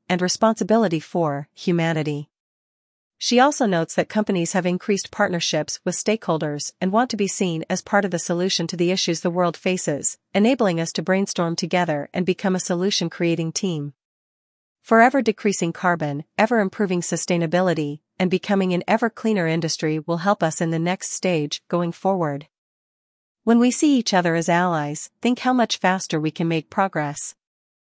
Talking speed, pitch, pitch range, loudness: 165 wpm, 180 Hz, 165-200 Hz, -21 LUFS